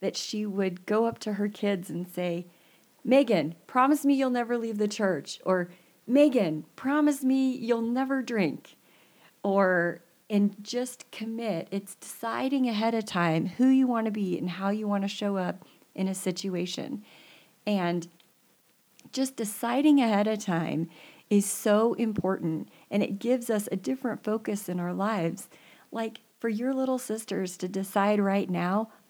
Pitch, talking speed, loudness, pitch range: 205 Hz, 155 wpm, -28 LUFS, 185-235 Hz